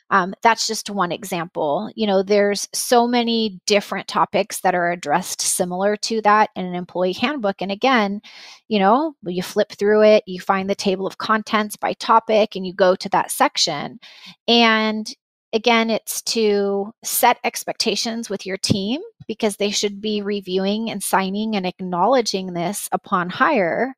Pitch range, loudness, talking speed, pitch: 190-220 Hz, -19 LUFS, 165 wpm, 205 Hz